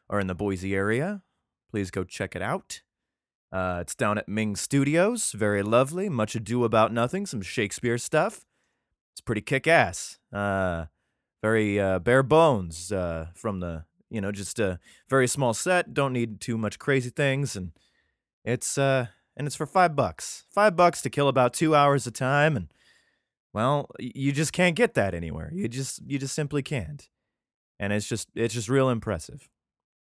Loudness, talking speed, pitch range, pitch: -26 LUFS, 175 wpm, 100-140 Hz, 120 Hz